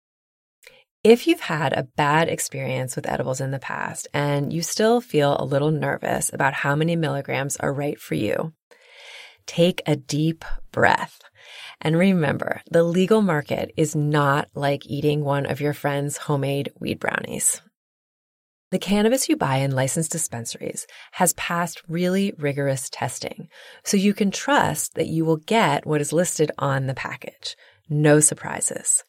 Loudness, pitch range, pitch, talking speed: -22 LUFS, 140-180 Hz, 155 Hz, 155 wpm